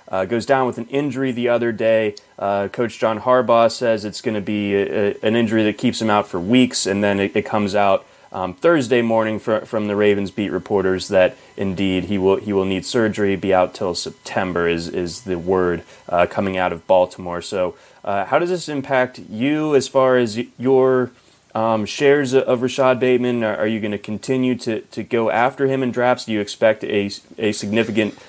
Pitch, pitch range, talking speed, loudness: 110 Hz, 100-125 Hz, 210 wpm, -19 LUFS